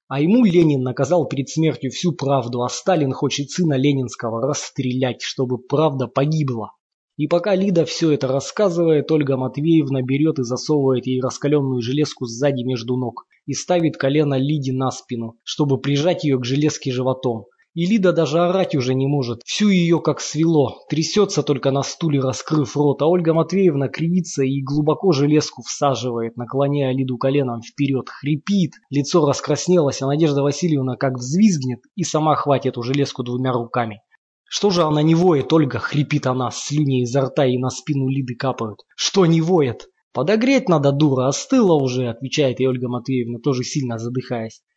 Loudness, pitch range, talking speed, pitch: -19 LUFS, 130-160 Hz, 160 wpm, 140 Hz